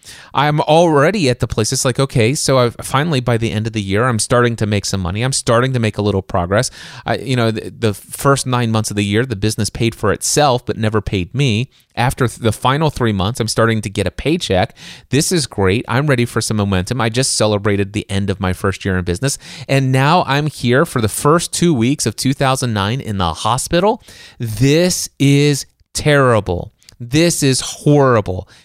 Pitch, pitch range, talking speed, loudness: 120 Hz, 105-135 Hz, 215 wpm, -16 LUFS